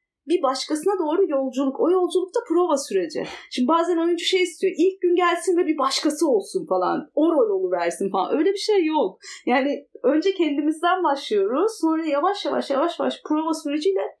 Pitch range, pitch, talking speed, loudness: 290-370 Hz, 330 Hz, 170 wpm, -22 LUFS